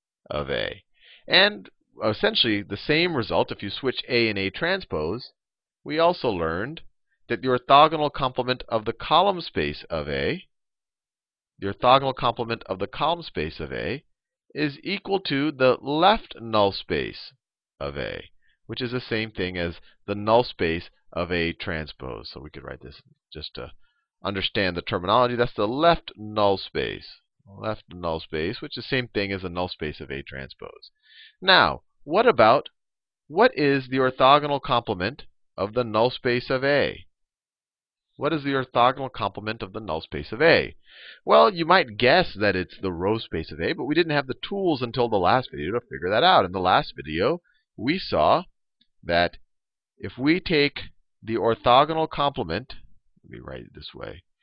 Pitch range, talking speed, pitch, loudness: 100-145 Hz, 175 wpm, 120 Hz, -23 LUFS